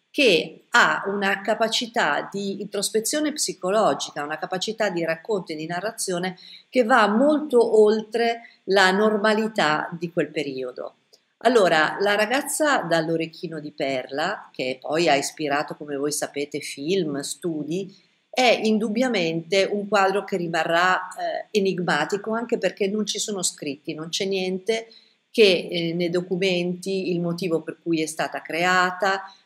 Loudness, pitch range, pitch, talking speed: -23 LUFS, 165-215 Hz, 190 Hz, 135 wpm